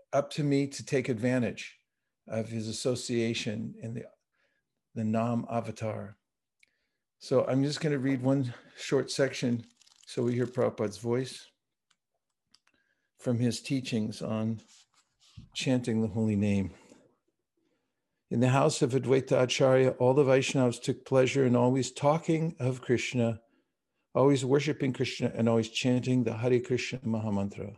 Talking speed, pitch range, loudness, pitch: 135 wpm, 115-135 Hz, -29 LUFS, 125 Hz